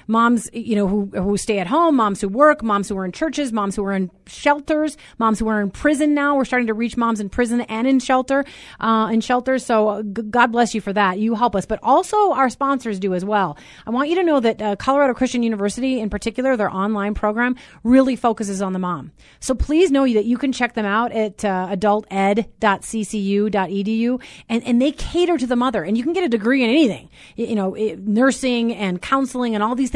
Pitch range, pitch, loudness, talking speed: 205-260 Hz, 230 Hz, -19 LUFS, 225 wpm